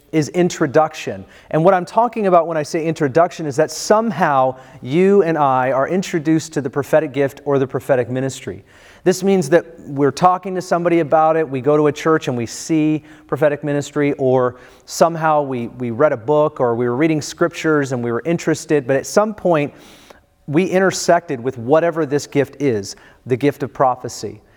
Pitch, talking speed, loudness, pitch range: 150 Hz, 190 wpm, -17 LUFS, 135-165 Hz